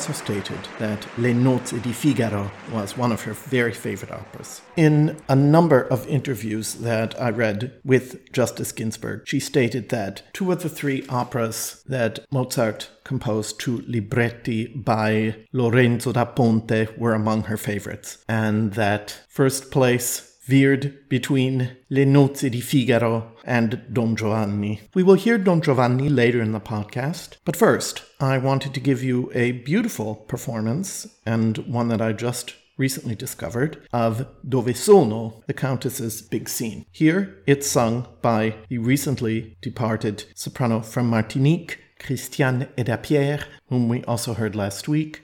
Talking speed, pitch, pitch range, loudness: 145 wpm, 120 Hz, 110-135 Hz, -22 LUFS